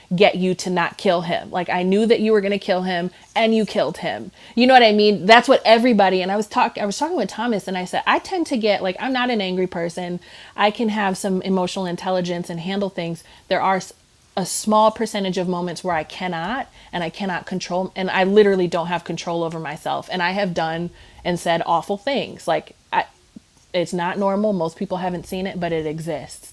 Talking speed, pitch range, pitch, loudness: 230 wpm, 175-210 Hz, 185 Hz, -20 LUFS